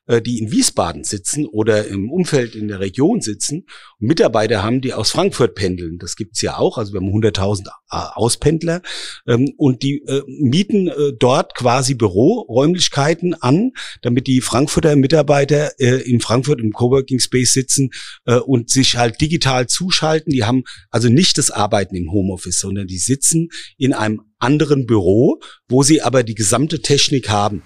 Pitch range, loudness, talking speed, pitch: 110-145 Hz, -16 LUFS, 155 wpm, 130 Hz